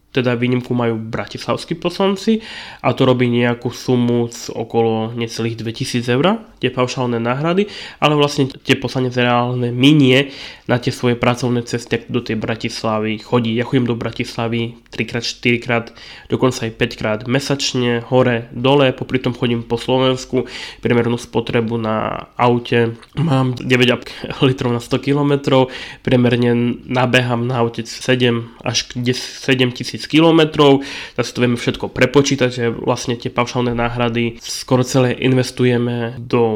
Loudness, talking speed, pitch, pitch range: -17 LUFS, 140 wpm, 125 Hz, 120-130 Hz